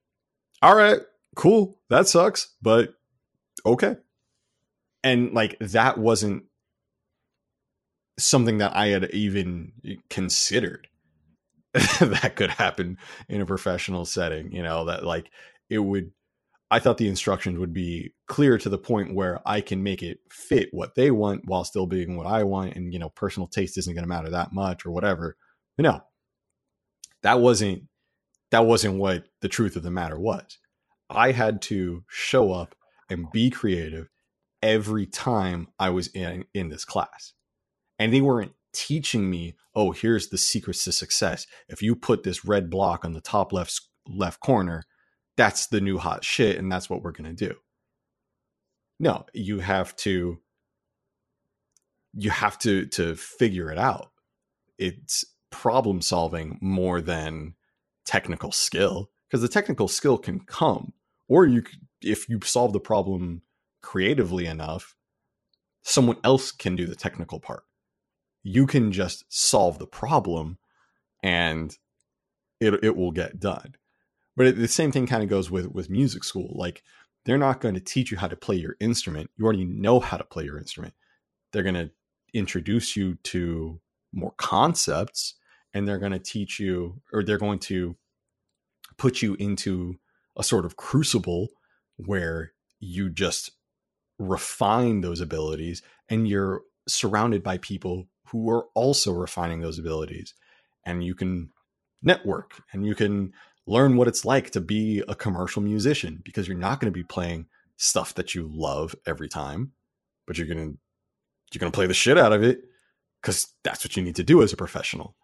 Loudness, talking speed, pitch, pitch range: -24 LUFS, 160 wpm, 95 Hz, 90-110 Hz